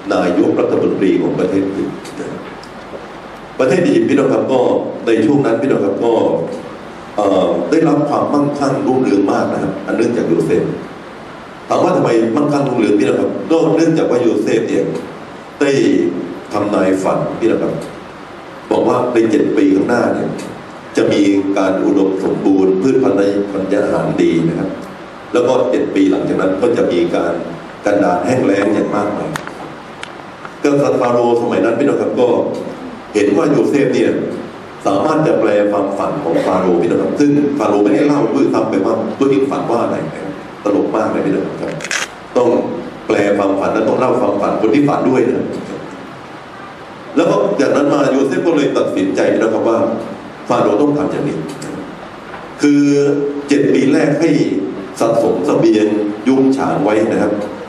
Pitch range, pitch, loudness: 100-145 Hz, 120 Hz, -14 LUFS